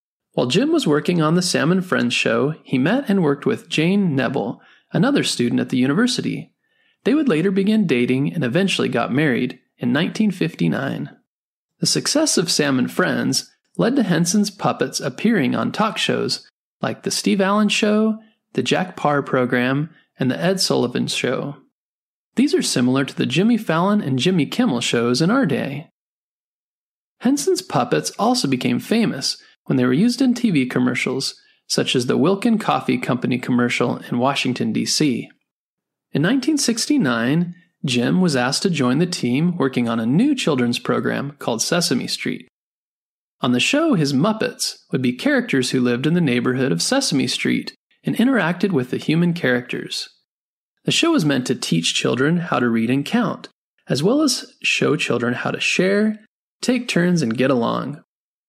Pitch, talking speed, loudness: 175 Hz, 165 wpm, -19 LUFS